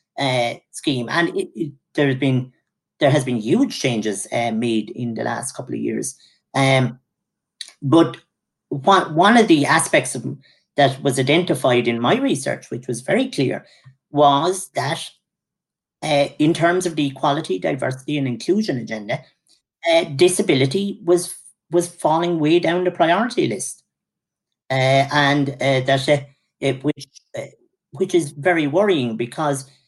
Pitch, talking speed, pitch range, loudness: 145 Hz, 150 wpm, 130-170 Hz, -19 LUFS